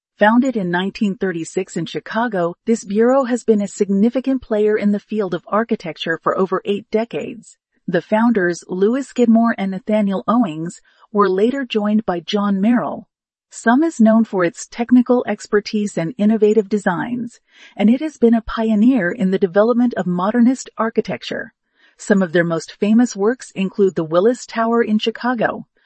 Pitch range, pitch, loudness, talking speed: 190-235 Hz, 215 Hz, -18 LUFS, 160 wpm